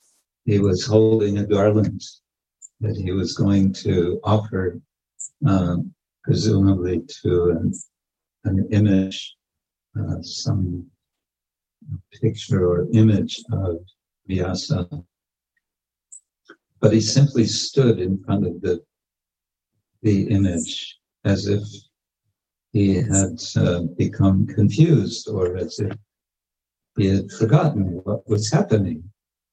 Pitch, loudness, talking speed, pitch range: 95 Hz, -21 LUFS, 100 wpm, 85-105 Hz